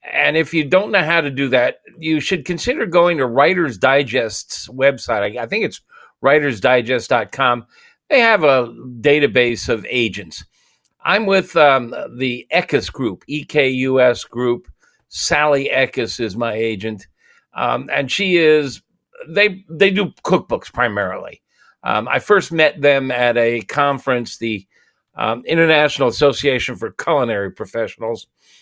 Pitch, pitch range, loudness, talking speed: 140 Hz, 120-165 Hz, -17 LUFS, 140 wpm